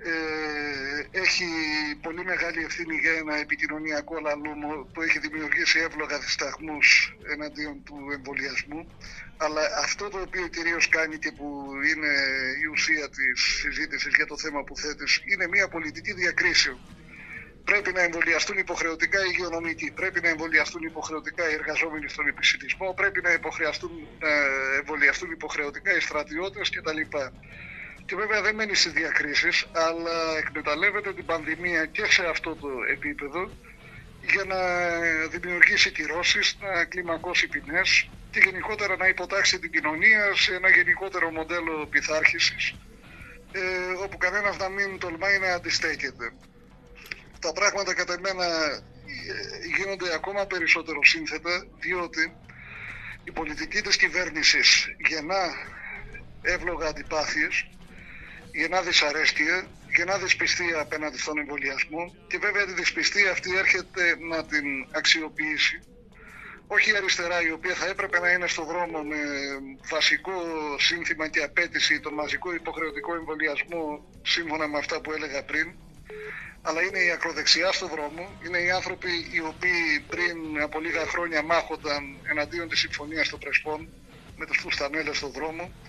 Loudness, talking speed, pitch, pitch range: -24 LUFS, 130 wpm, 160 Hz, 150-180 Hz